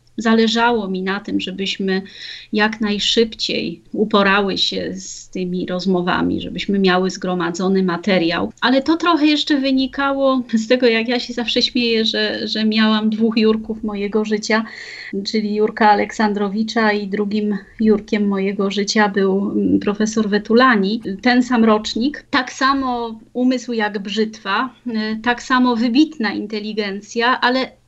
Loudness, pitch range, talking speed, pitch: -18 LUFS, 200-240 Hz, 125 wpm, 215 Hz